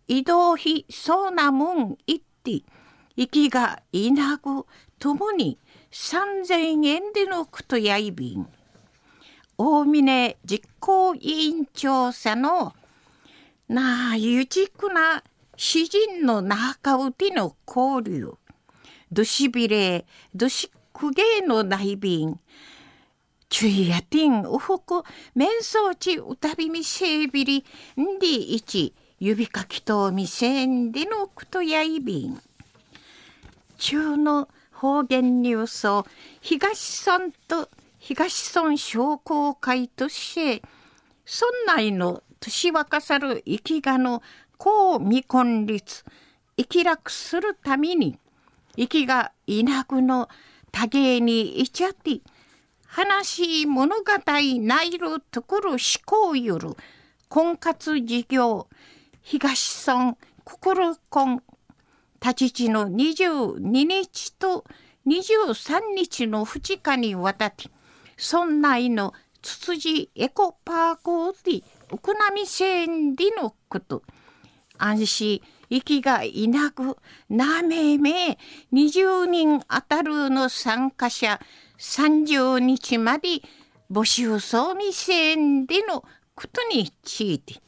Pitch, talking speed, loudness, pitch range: 290 Hz, 170 characters per minute, -23 LUFS, 245-340 Hz